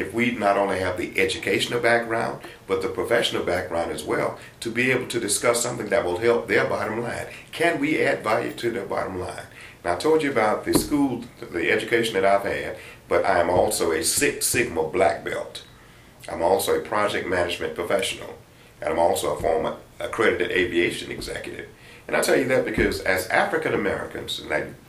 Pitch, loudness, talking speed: 120 Hz, -23 LUFS, 190 wpm